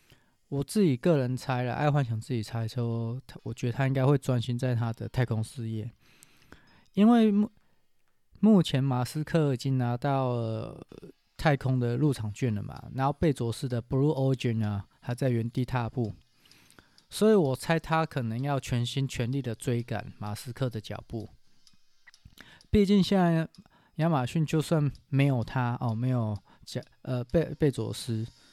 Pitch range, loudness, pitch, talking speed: 120-150 Hz, -28 LUFS, 130 Hz, 250 characters per minute